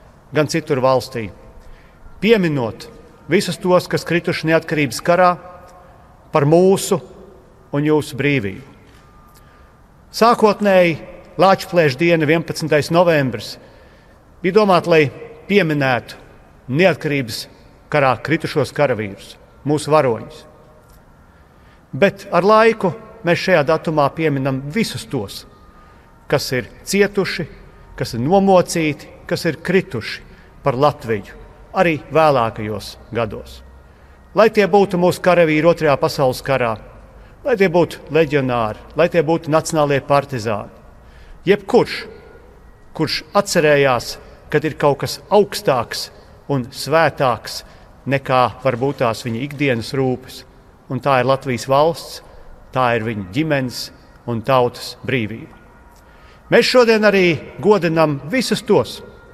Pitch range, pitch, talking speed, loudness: 125-175 Hz, 150 Hz, 105 wpm, -17 LUFS